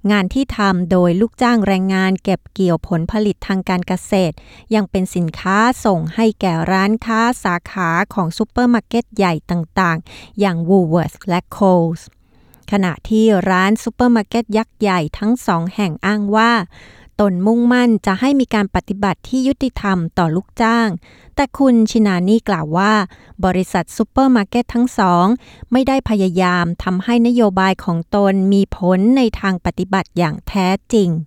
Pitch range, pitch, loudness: 180-225 Hz, 195 Hz, -16 LUFS